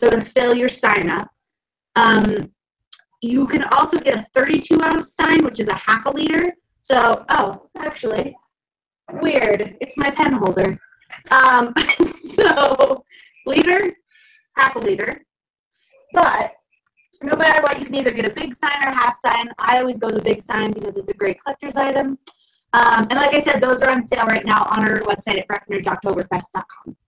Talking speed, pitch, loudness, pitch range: 175 wpm, 270 Hz, -17 LUFS, 225-315 Hz